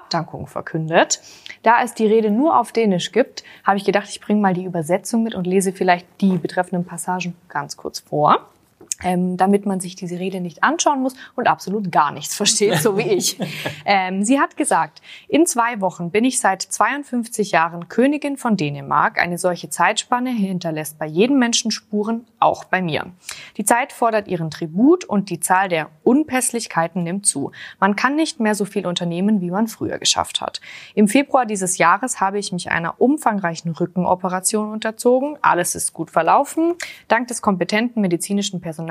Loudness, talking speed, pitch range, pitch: -19 LUFS, 175 wpm, 180-230 Hz, 200 Hz